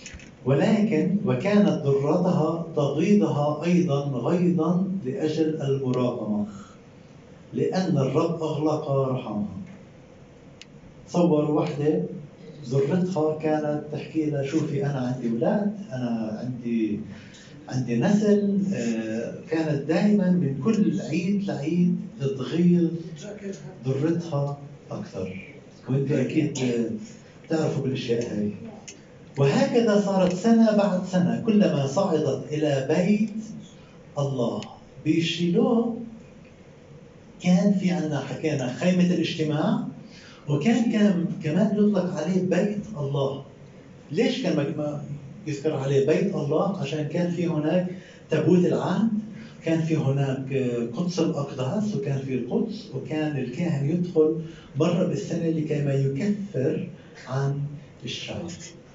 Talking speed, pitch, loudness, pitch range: 95 wpm, 160 Hz, -25 LUFS, 140-180 Hz